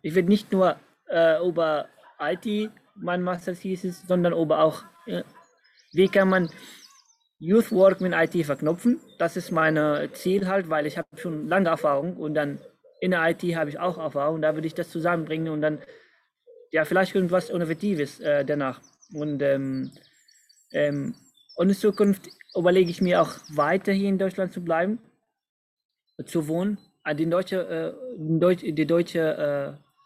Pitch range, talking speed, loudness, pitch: 155-190 Hz, 160 wpm, -25 LUFS, 175 Hz